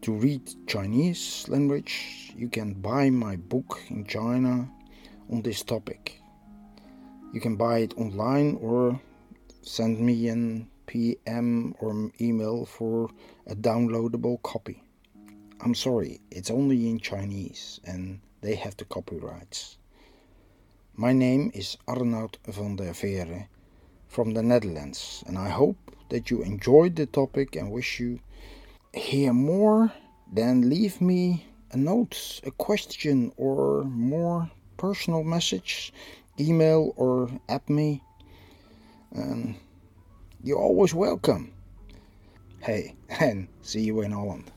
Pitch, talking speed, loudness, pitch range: 115 Hz, 120 wpm, -27 LUFS, 100-135 Hz